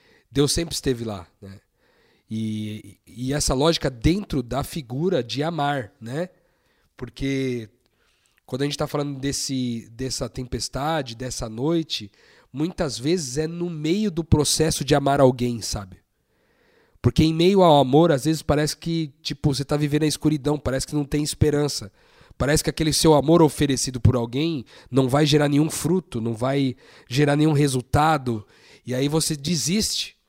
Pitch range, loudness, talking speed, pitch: 125-155 Hz, -22 LUFS, 155 wpm, 145 Hz